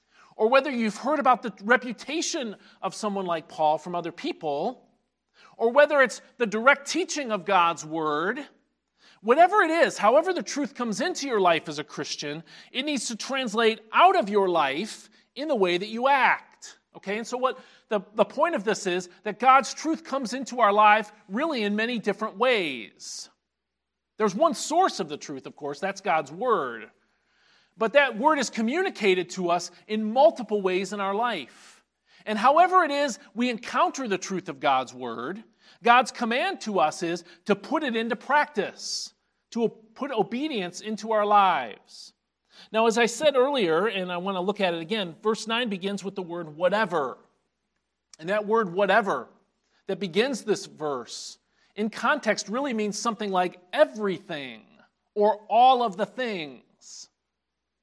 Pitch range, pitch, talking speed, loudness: 195-265 Hz, 220 Hz, 170 wpm, -25 LUFS